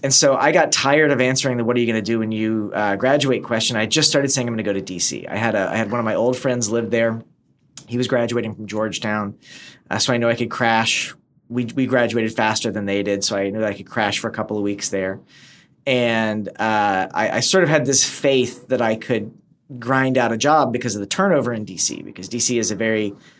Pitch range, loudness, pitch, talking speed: 105-125 Hz, -19 LUFS, 115 Hz, 255 wpm